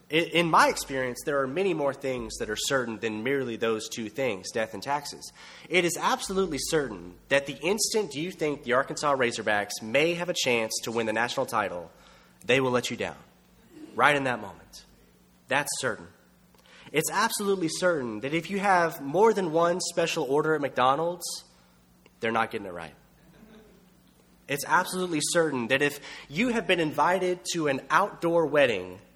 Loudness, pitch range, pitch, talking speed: -27 LUFS, 115-175 Hz, 145 Hz, 170 wpm